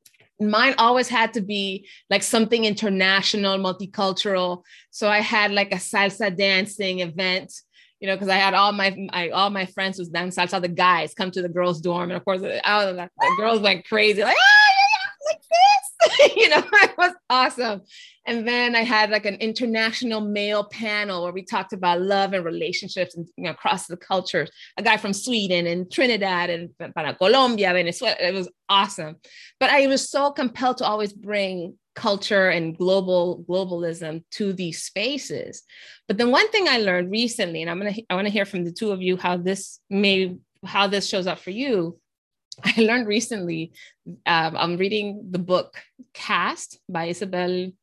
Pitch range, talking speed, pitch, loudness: 180-225 Hz, 185 wpm, 195 Hz, -21 LUFS